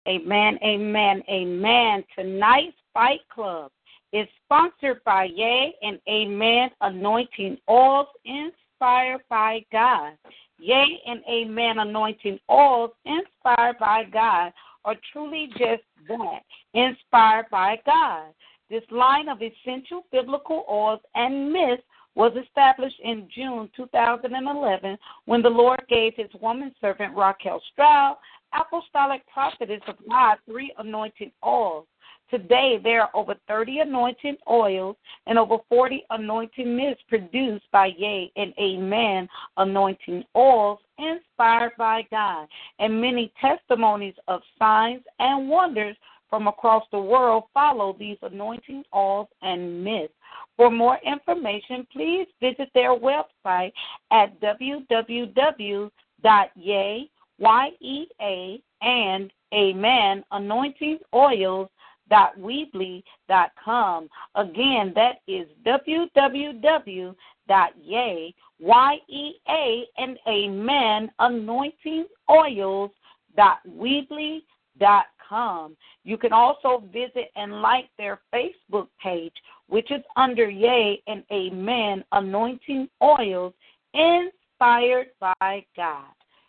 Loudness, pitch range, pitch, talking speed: -22 LUFS, 205-265 Hz, 230 Hz, 105 wpm